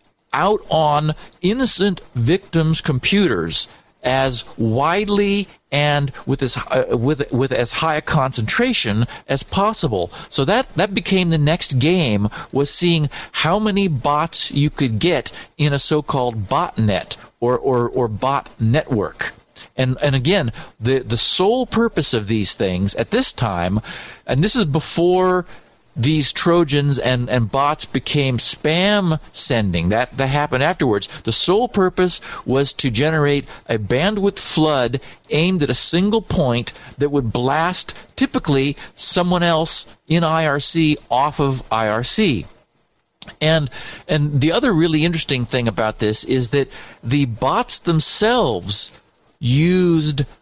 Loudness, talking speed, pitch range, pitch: -17 LUFS, 135 wpm, 125-170 Hz, 145 Hz